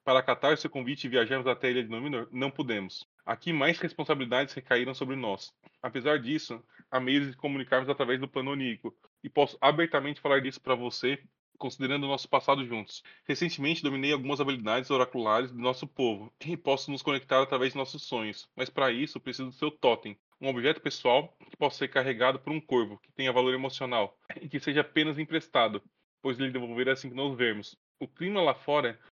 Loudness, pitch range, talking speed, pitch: -30 LUFS, 130-145 Hz, 195 wpm, 135 Hz